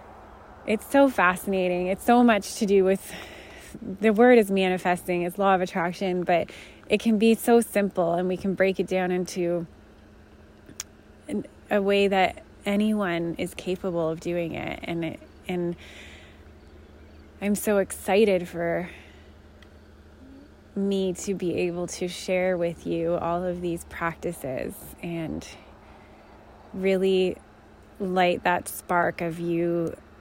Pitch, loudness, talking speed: 175 Hz, -25 LUFS, 130 wpm